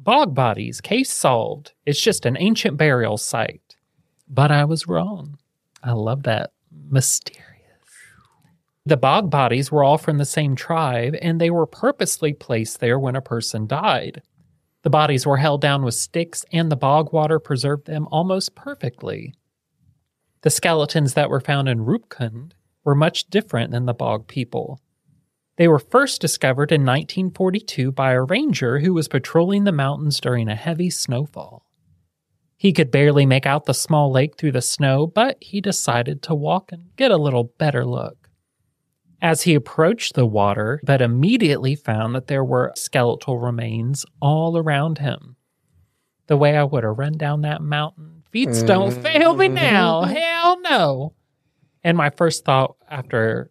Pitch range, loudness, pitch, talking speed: 130-165 Hz, -19 LUFS, 150 Hz, 160 wpm